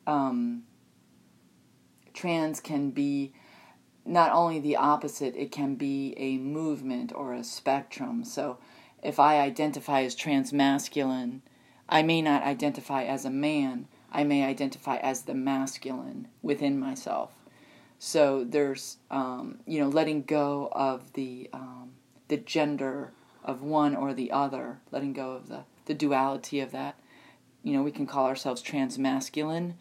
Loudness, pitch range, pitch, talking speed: -29 LUFS, 135-150 Hz, 140 Hz, 140 wpm